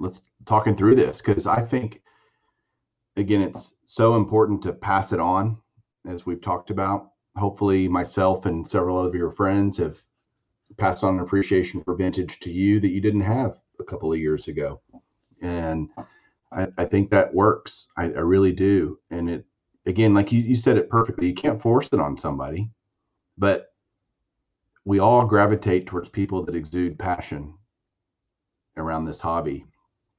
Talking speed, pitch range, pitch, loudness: 160 wpm, 90-105 Hz, 95 Hz, -22 LUFS